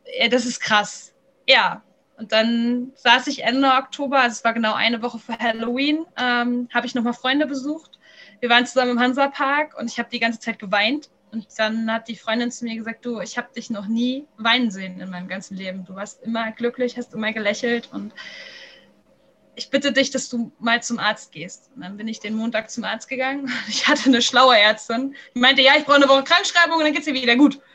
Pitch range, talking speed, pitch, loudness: 225-270 Hz, 225 wpm, 240 Hz, -19 LUFS